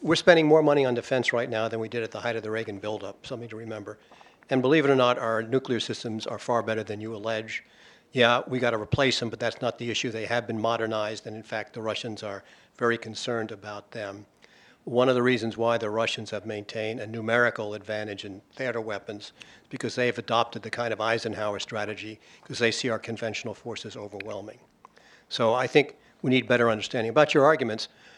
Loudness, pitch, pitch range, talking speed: -26 LUFS, 115 Hz, 110-120 Hz, 215 wpm